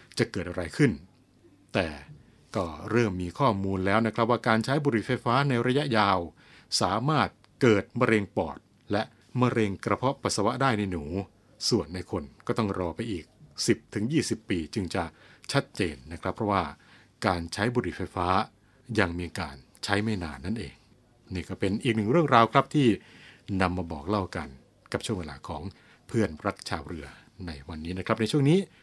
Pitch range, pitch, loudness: 90-120 Hz, 105 Hz, -28 LUFS